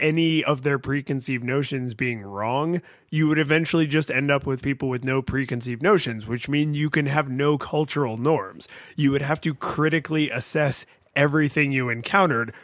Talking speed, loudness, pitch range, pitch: 170 wpm, -23 LUFS, 130-155 Hz, 145 Hz